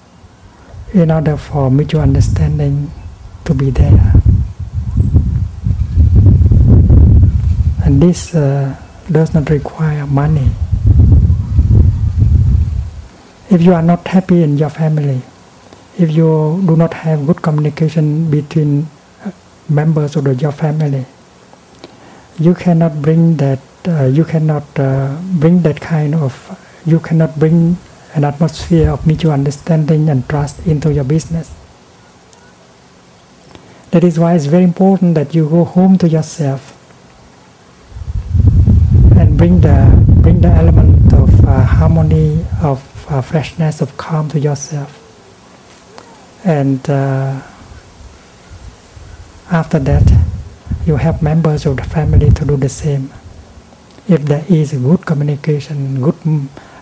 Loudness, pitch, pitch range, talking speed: -12 LUFS, 140 Hz, 95-160 Hz, 115 wpm